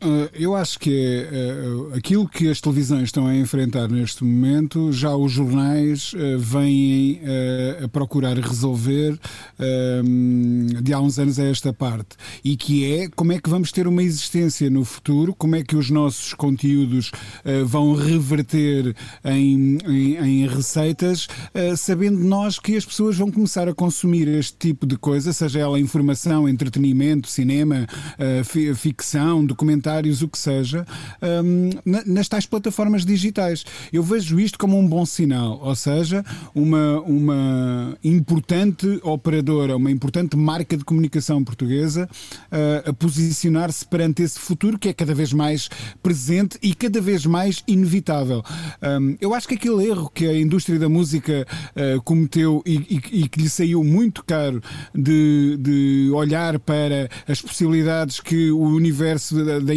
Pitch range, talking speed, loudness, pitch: 140-170 Hz, 150 wpm, -20 LUFS, 150 Hz